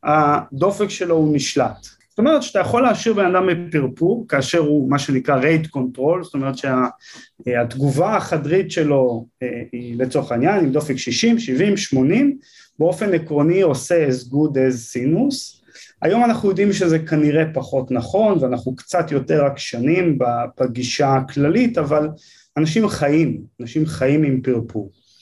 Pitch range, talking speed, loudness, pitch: 130-180 Hz, 140 wpm, -18 LUFS, 150 Hz